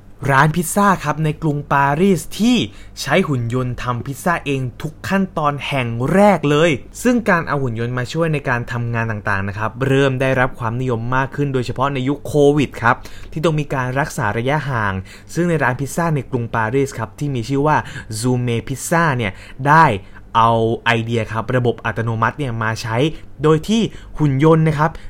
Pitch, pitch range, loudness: 135 Hz, 115-150 Hz, -18 LUFS